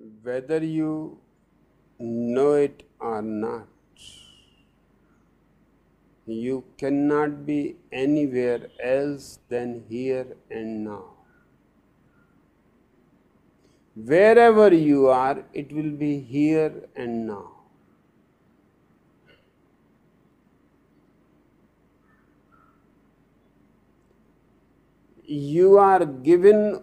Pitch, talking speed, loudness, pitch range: 135 Hz, 60 wpm, -22 LUFS, 115-150 Hz